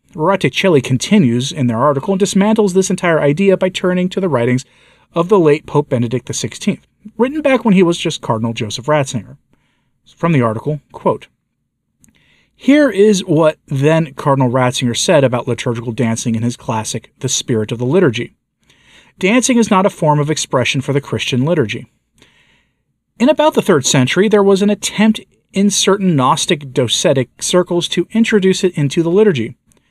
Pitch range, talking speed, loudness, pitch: 125-195 Hz, 165 wpm, -14 LUFS, 155 Hz